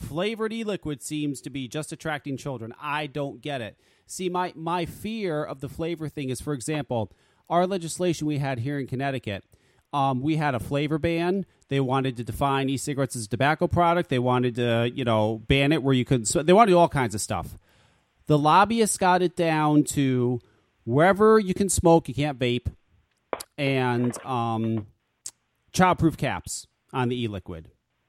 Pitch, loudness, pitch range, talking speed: 140 Hz, -25 LUFS, 125-165 Hz, 185 wpm